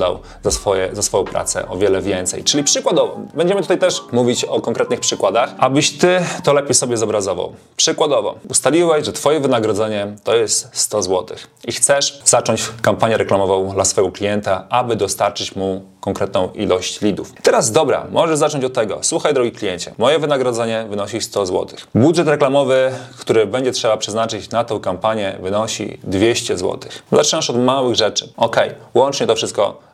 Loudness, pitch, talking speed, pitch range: -17 LUFS, 115 Hz, 160 wpm, 100-140 Hz